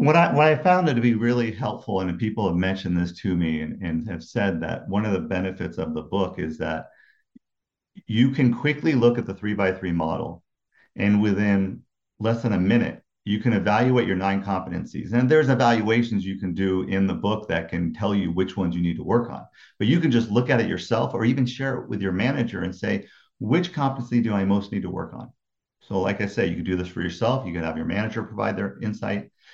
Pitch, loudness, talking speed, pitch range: 100 Hz, -24 LUFS, 240 wpm, 95-120 Hz